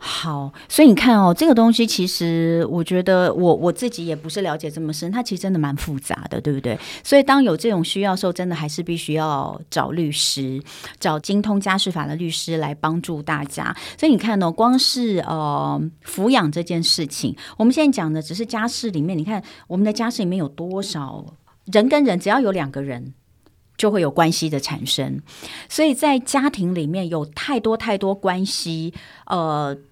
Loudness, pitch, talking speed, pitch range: -20 LUFS, 170 Hz, 290 characters per minute, 155-210 Hz